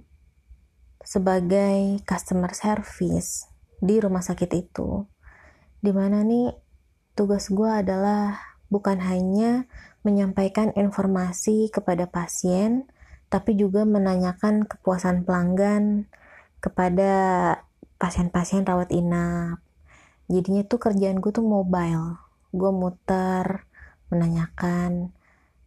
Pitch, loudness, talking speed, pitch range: 190 Hz, -24 LUFS, 85 wpm, 175-205 Hz